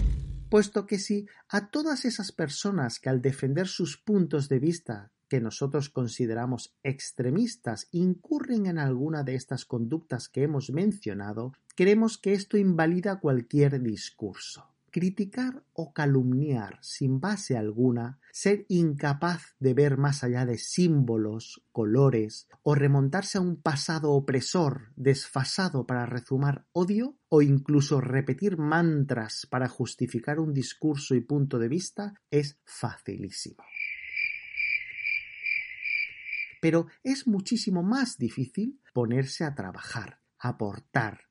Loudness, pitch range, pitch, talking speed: -28 LUFS, 130-200 Hz, 150 Hz, 120 wpm